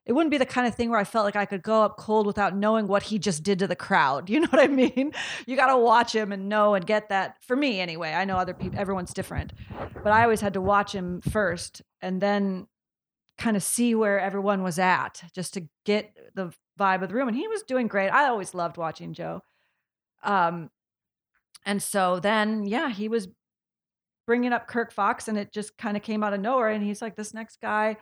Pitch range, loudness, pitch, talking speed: 190-230 Hz, -25 LUFS, 210 Hz, 235 wpm